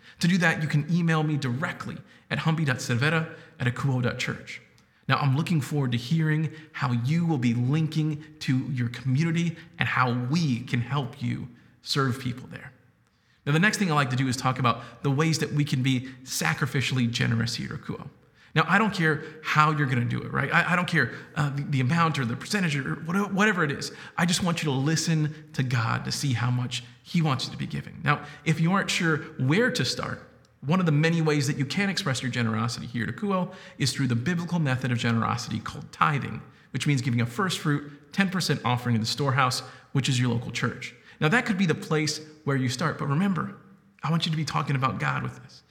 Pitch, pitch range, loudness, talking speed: 145 Hz, 125-160 Hz, -26 LUFS, 225 wpm